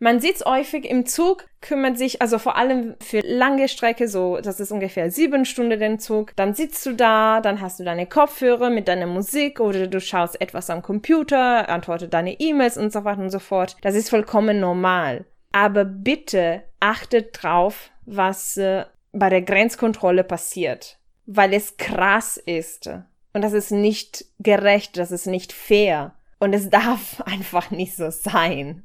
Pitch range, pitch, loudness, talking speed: 185-235 Hz, 205 Hz, -20 LUFS, 170 wpm